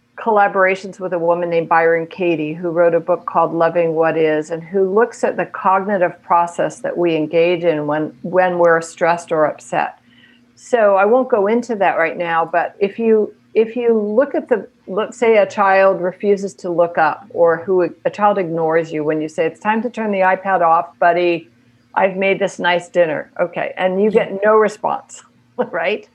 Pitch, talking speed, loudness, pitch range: 175 Hz, 195 wpm, -16 LUFS, 165-200 Hz